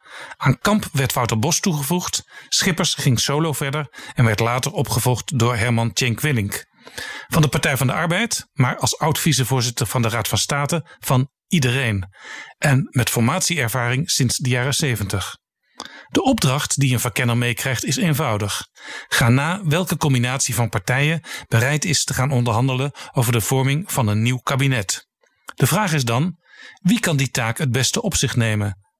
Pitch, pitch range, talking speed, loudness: 130 Hz, 120-150 Hz, 165 wpm, -20 LUFS